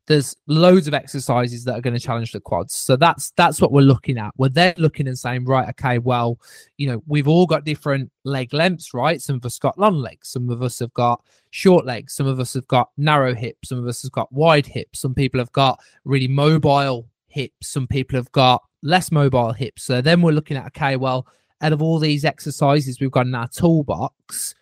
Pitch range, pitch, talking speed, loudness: 125-150 Hz, 135 Hz, 225 wpm, -19 LUFS